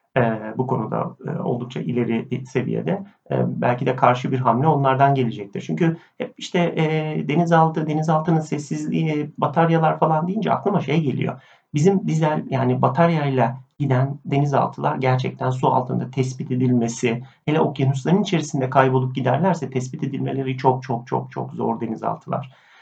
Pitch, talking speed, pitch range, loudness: 135 Hz, 135 wpm, 130-160 Hz, -21 LUFS